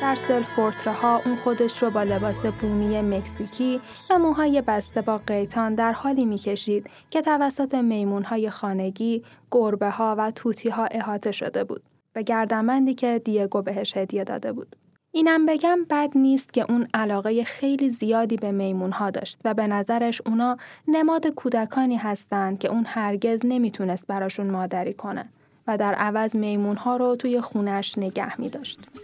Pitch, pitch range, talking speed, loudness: 225 Hz, 205-250 Hz, 155 wpm, -24 LUFS